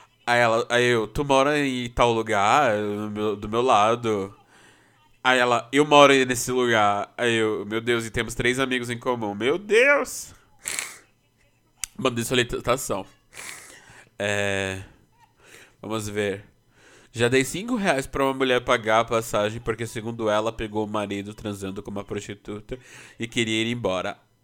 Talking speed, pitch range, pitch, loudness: 150 wpm, 105-125 Hz, 115 Hz, -23 LUFS